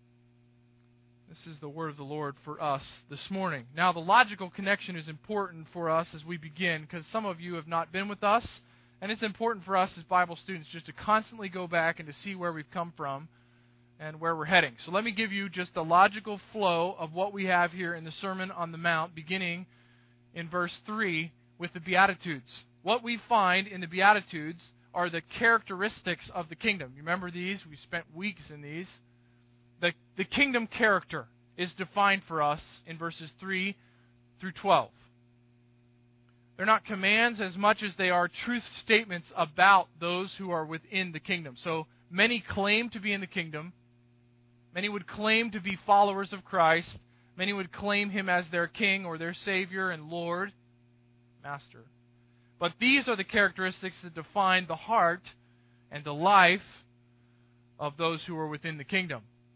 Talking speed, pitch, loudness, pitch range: 180 wpm, 170 Hz, -29 LUFS, 145-195 Hz